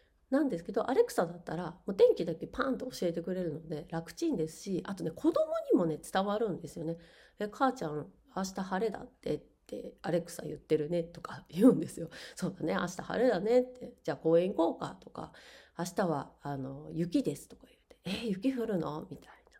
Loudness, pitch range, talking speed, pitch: -33 LUFS, 165-240 Hz, 390 characters per minute, 180 Hz